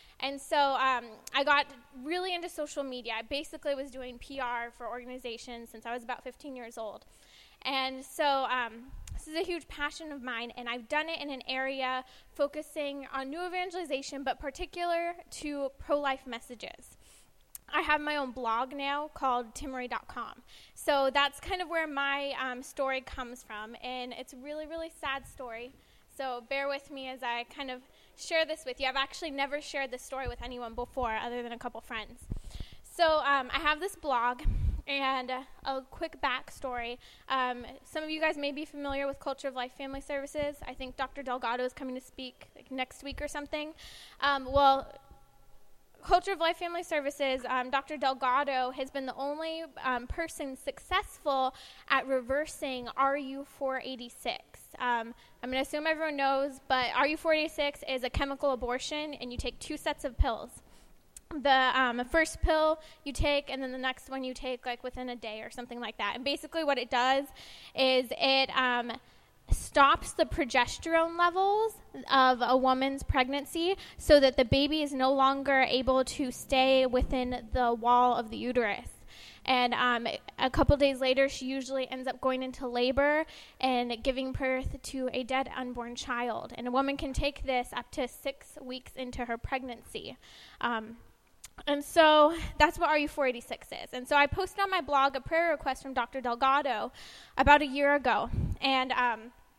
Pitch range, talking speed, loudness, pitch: 250-290 Hz, 180 wpm, -31 LUFS, 270 Hz